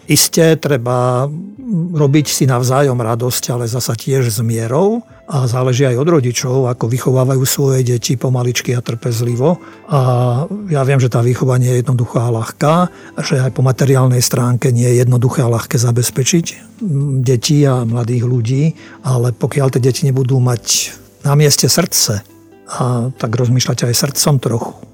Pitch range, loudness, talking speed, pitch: 125-145 Hz, -14 LUFS, 155 wpm, 130 Hz